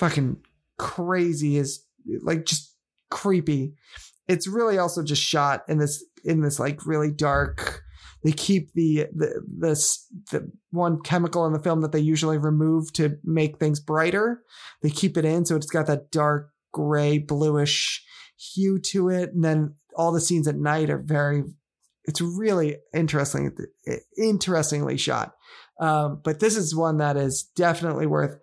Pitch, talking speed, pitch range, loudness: 155 Hz, 160 wpm, 150-170 Hz, -24 LUFS